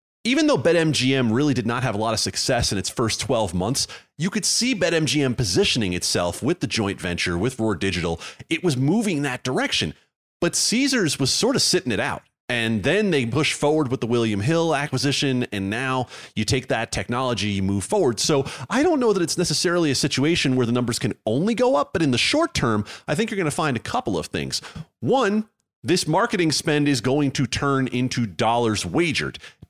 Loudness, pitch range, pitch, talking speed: -22 LUFS, 115-160 Hz, 130 Hz, 210 wpm